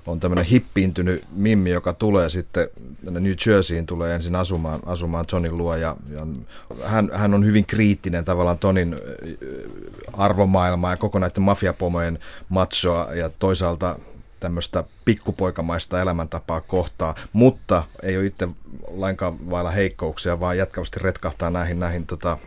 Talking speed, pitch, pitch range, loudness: 135 wpm, 90 Hz, 85-95 Hz, -22 LUFS